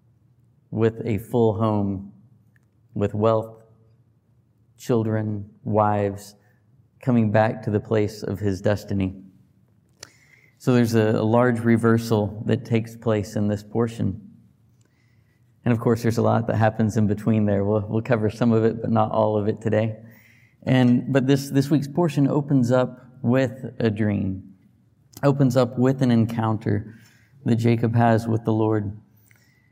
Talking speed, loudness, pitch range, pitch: 145 wpm, -22 LUFS, 110-120 Hz, 115 Hz